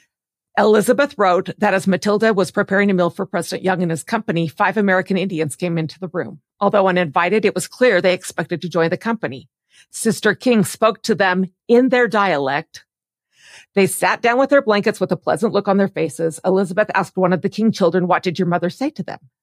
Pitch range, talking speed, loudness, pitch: 175-210 Hz, 210 wpm, -18 LUFS, 190 Hz